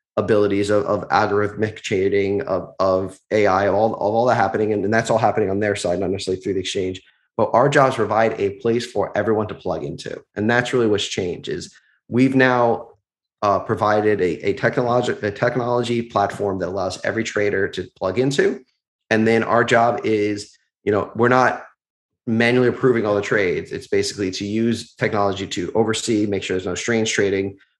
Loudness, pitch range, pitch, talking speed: -20 LUFS, 100-115 Hz, 105 Hz, 190 wpm